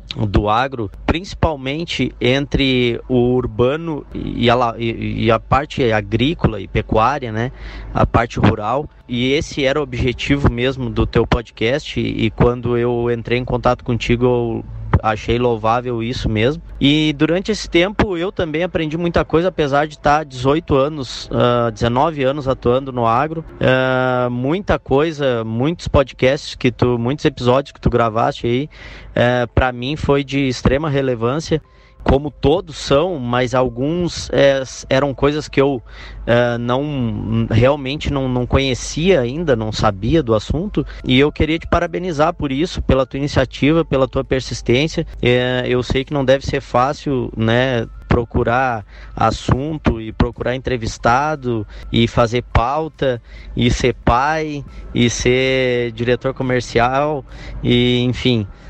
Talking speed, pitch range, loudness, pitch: 140 wpm, 120-140 Hz, -17 LUFS, 125 Hz